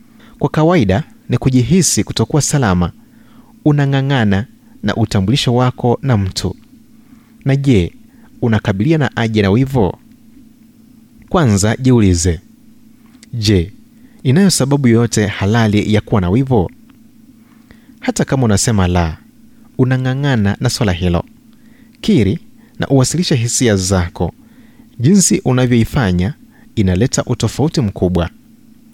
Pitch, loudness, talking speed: 130 Hz, -14 LUFS, 100 wpm